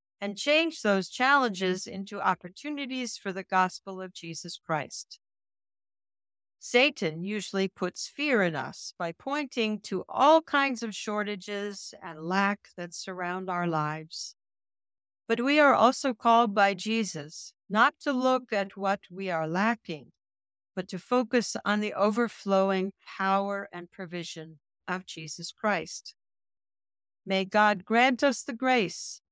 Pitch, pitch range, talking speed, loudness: 200 Hz, 180-250 Hz, 130 wpm, -28 LUFS